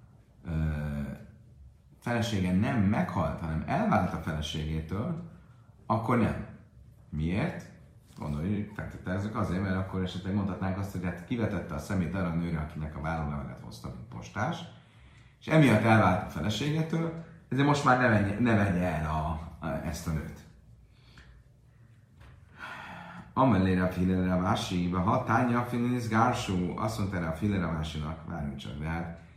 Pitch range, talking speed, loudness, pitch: 80-115 Hz, 130 wpm, -30 LUFS, 95 Hz